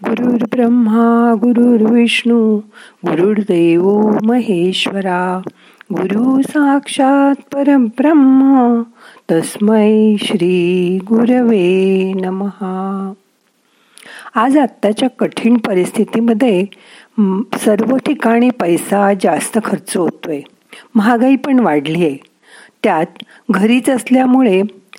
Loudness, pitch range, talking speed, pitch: -13 LUFS, 195-245 Hz, 65 wpm, 225 Hz